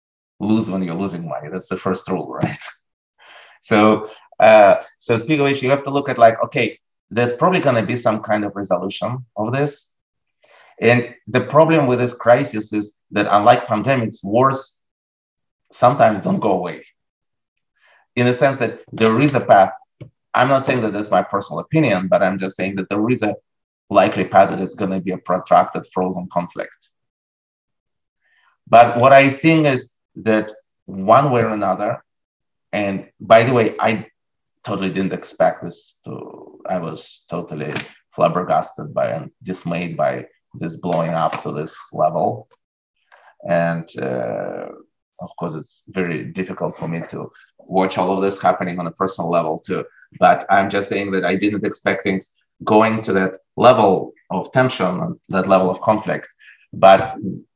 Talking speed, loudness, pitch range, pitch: 165 wpm, -18 LUFS, 95-125 Hz, 105 Hz